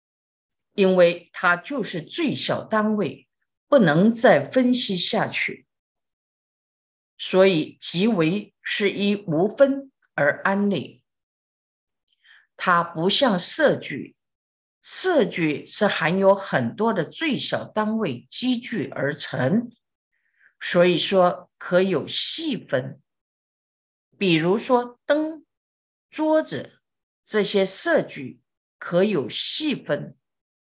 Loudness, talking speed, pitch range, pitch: -22 LUFS, 135 characters per minute, 175-245 Hz, 200 Hz